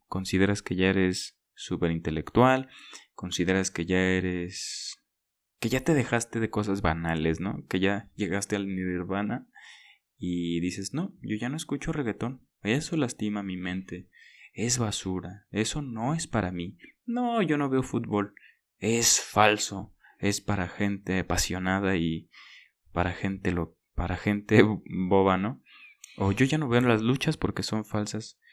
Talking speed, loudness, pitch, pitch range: 150 wpm, -28 LUFS, 100 Hz, 90-115 Hz